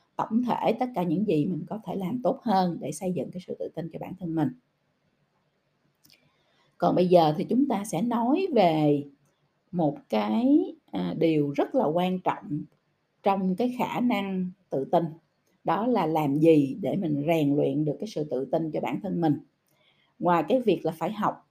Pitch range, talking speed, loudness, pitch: 155-200 Hz, 190 wpm, -26 LUFS, 170 Hz